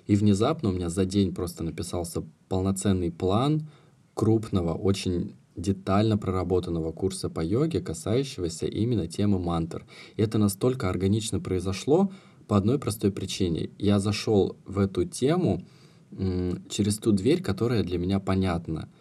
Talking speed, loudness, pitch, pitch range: 135 wpm, -27 LUFS, 100 Hz, 90-110 Hz